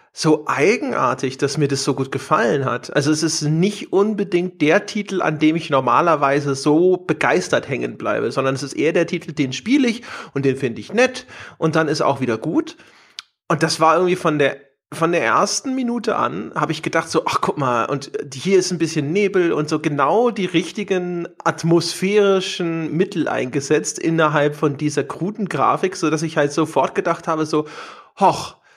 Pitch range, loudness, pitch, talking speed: 145-185 Hz, -19 LUFS, 160 Hz, 190 wpm